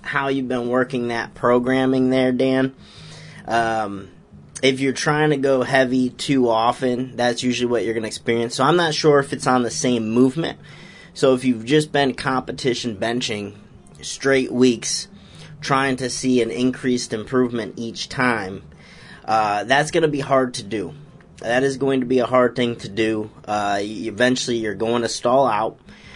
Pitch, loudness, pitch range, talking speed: 125 Hz, -20 LUFS, 115-130 Hz, 175 wpm